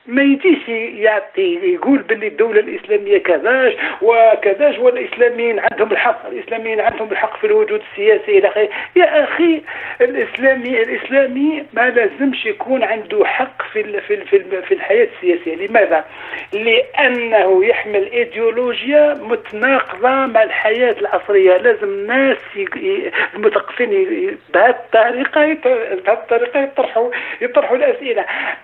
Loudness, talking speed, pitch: -15 LUFS, 105 wpm, 300 Hz